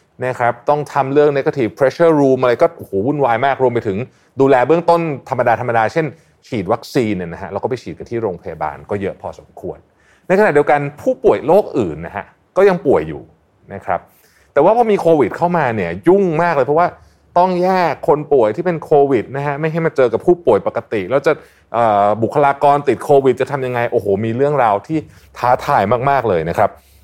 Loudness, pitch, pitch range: -15 LUFS, 140 Hz, 120-165 Hz